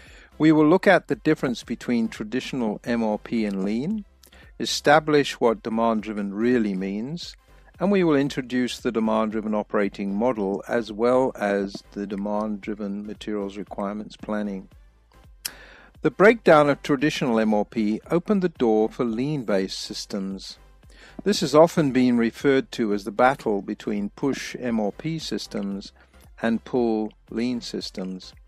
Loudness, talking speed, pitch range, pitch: -23 LUFS, 135 wpm, 105-145 Hz, 115 Hz